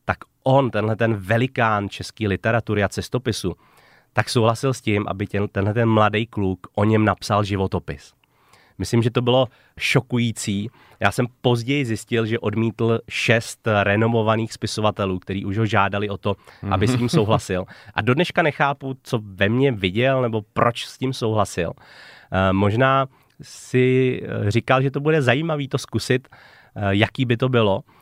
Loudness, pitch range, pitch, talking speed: -21 LUFS, 100-125 Hz, 115 Hz, 155 wpm